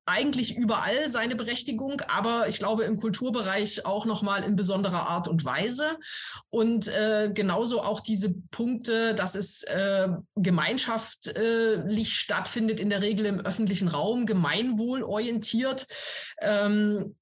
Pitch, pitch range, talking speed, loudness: 215 Hz, 200-230 Hz, 125 wpm, -26 LUFS